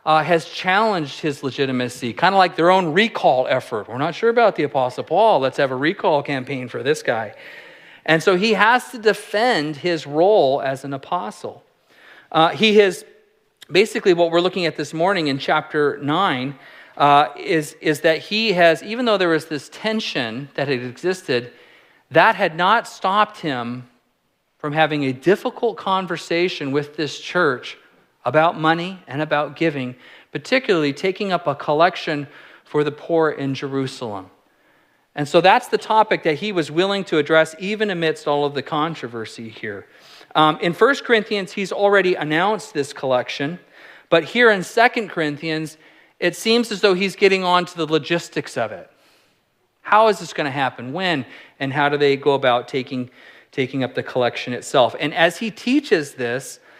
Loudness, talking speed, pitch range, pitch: -19 LUFS, 170 wpm, 145-195 Hz, 160 Hz